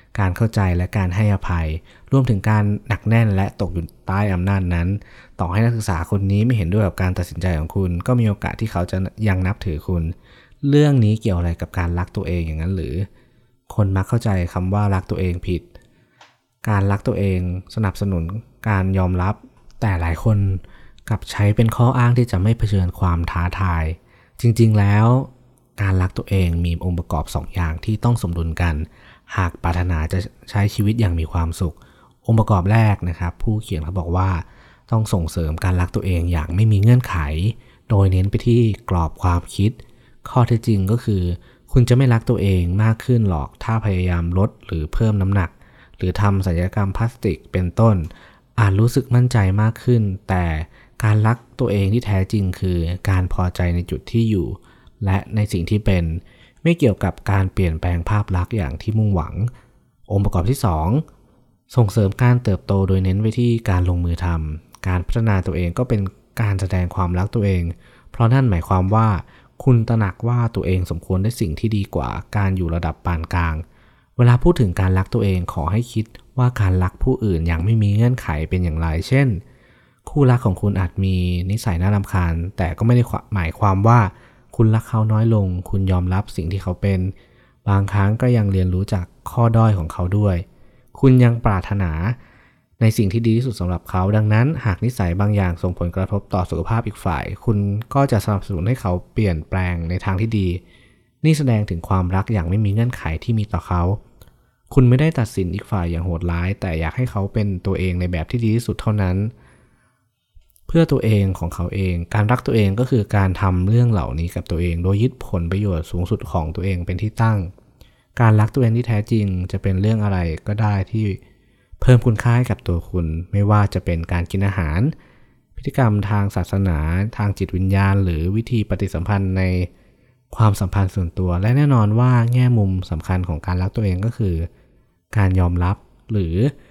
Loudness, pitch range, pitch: -19 LUFS, 90-115 Hz, 100 Hz